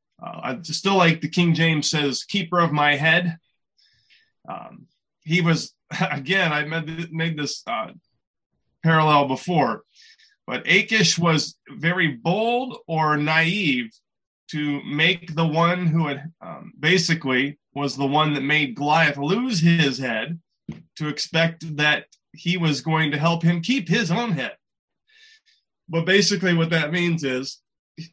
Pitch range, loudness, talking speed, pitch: 150-180 Hz, -21 LUFS, 145 wpm, 165 Hz